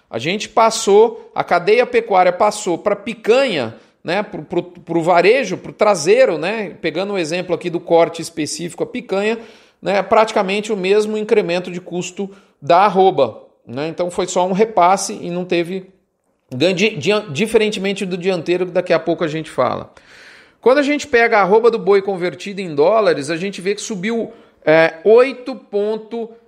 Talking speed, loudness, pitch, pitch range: 170 wpm, -16 LUFS, 195 Hz, 175-220 Hz